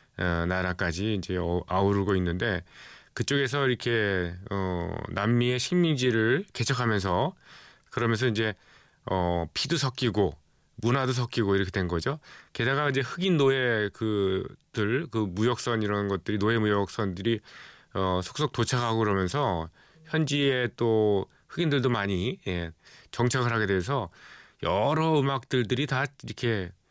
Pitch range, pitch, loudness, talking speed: 95-130 Hz, 110 Hz, -27 LUFS, 280 characters per minute